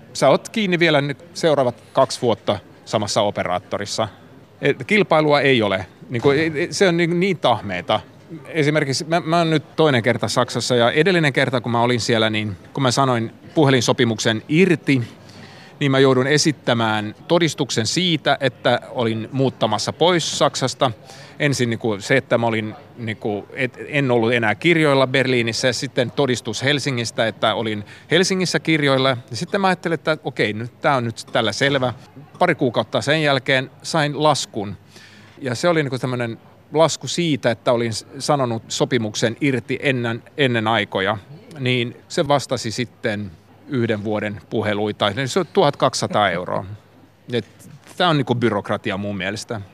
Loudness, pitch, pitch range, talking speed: -19 LUFS, 130 Hz, 115-150 Hz, 150 wpm